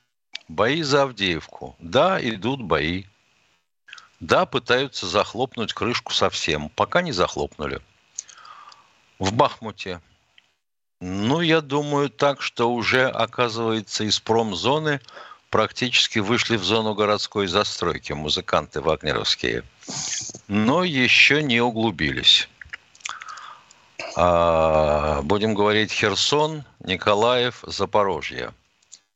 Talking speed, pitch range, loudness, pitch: 90 wpm, 90-125 Hz, -21 LUFS, 110 Hz